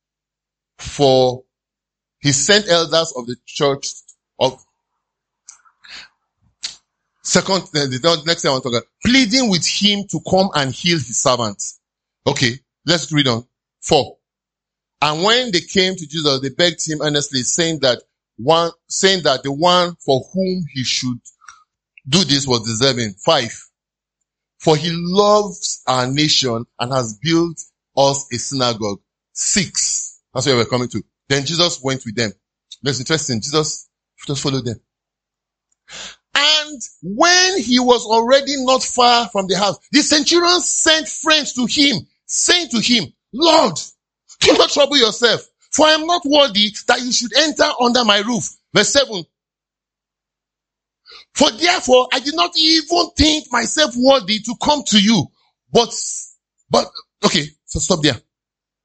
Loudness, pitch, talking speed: -16 LUFS, 180 Hz, 145 wpm